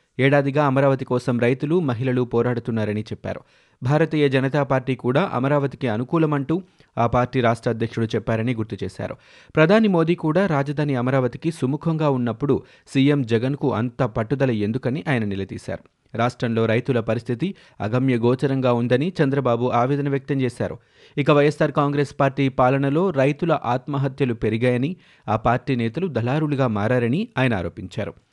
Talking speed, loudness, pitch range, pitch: 125 wpm, -21 LUFS, 120-145 Hz, 130 Hz